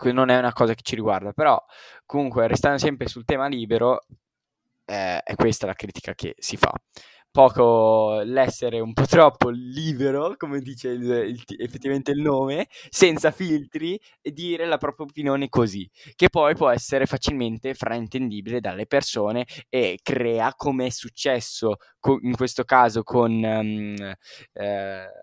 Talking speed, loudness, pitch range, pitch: 145 wpm, -22 LUFS, 115-140 Hz, 130 Hz